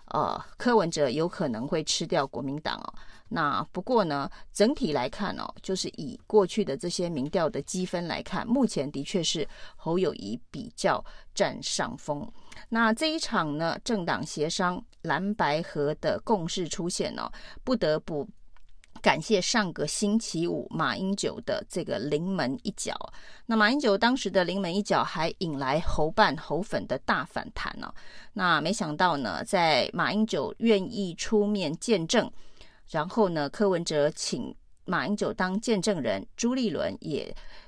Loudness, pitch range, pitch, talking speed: -28 LUFS, 160-215 Hz, 190 Hz, 235 characters per minute